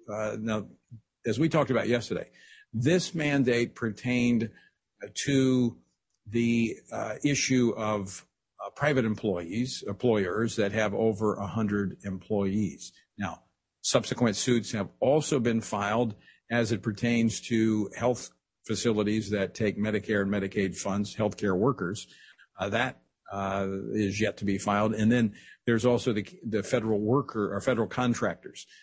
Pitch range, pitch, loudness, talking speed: 105-120 Hz, 110 Hz, -28 LUFS, 135 wpm